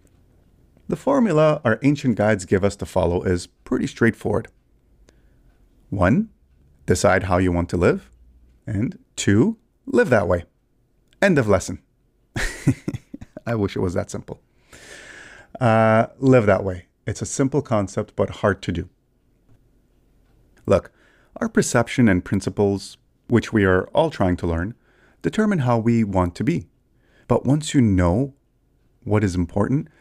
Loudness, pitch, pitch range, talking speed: -21 LUFS, 105 Hz, 90-120 Hz, 140 wpm